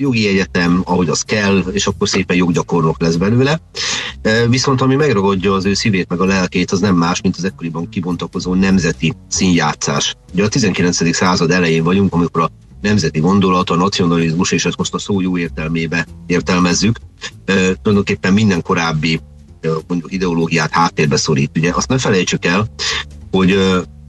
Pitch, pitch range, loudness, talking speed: 90 Hz, 85-95 Hz, -15 LUFS, 150 wpm